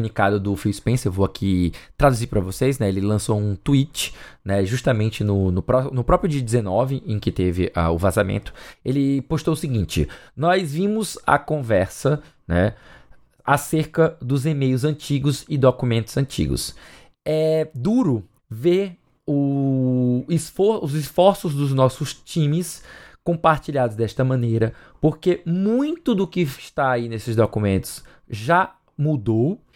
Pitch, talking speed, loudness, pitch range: 130 Hz, 135 wpm, -21 LUFS, 110-155 Hz